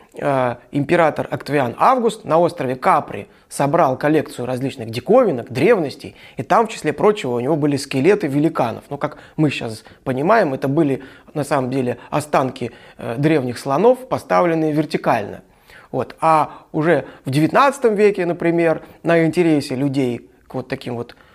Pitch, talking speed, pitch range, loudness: 150 Hz, 145 wpm, 130-165 Hz, -18 LUFS